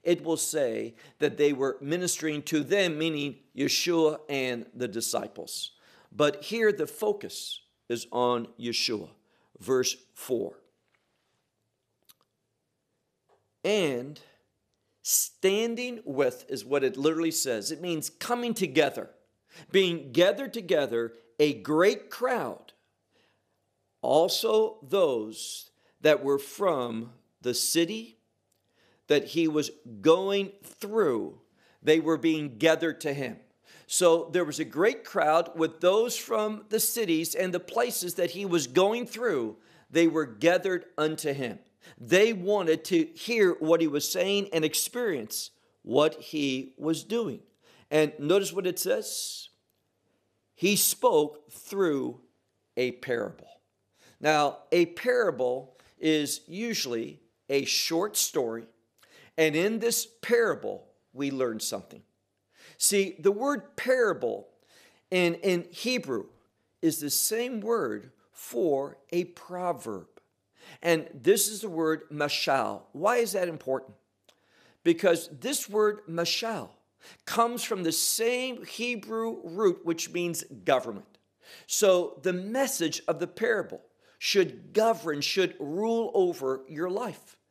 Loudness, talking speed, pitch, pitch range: -28 LUFS, 120 wpm, 170 Hz, 145-215 Hz